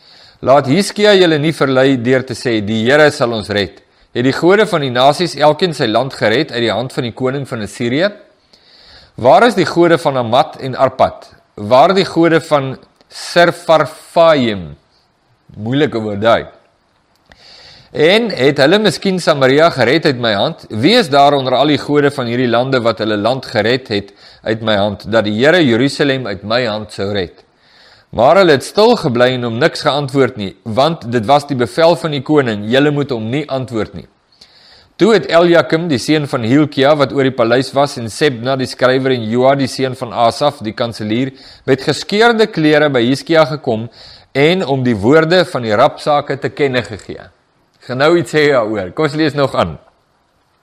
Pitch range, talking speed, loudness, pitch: 115-150 Hz, 185 wpm, -13 LUFS, 135 Hz